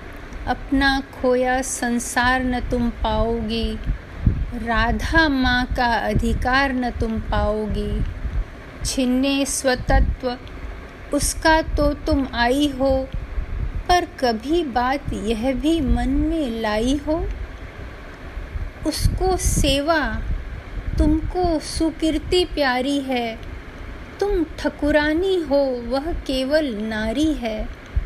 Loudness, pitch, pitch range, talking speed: -21 LUFS, 270 Hz, 240-305 Hz, 90 wpm